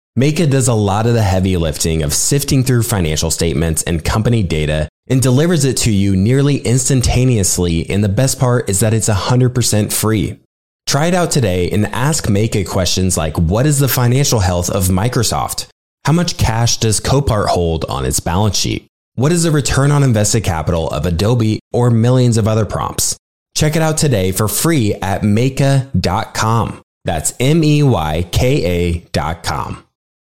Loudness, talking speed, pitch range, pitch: -14 LUFS, 160 wpm, 90-130 Hz, 110 Hz